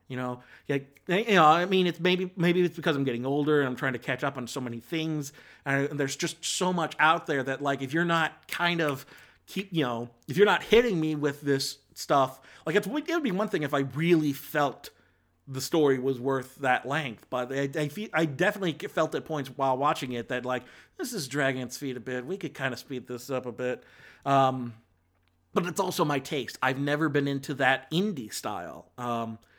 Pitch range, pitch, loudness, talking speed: 130-165 Hz, 140 Hz, -28 LUFS, 230 wpm